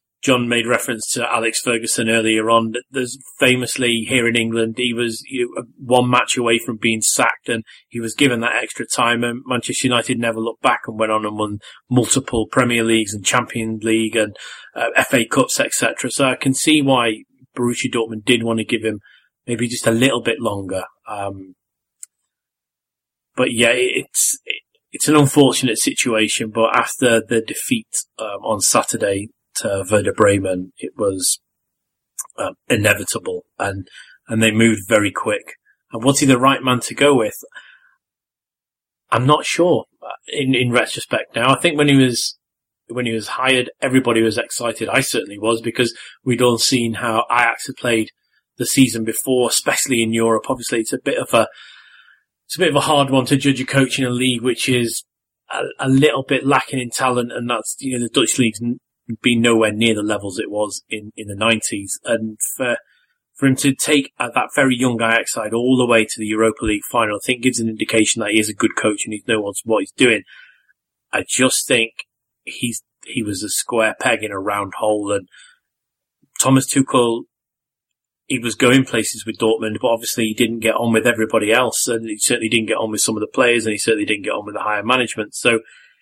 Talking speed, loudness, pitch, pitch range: 195 wpm, -18 LUFS, 120 Hz, 110-130 Hz